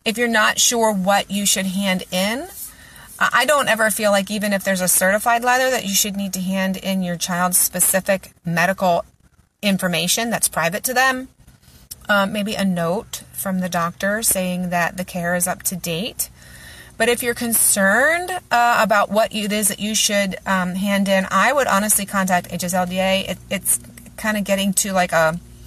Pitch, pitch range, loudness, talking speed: 195 Hz, 180-215 Hz, -18 LUFS, 185 wpm